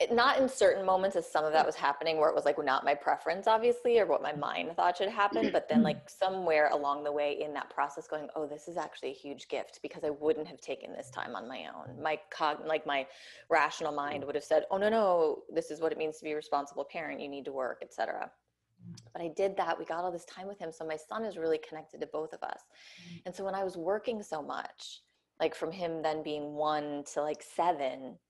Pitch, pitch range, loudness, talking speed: 160 Hz, 150-190 Hz, -32 LUFS, 250 wpm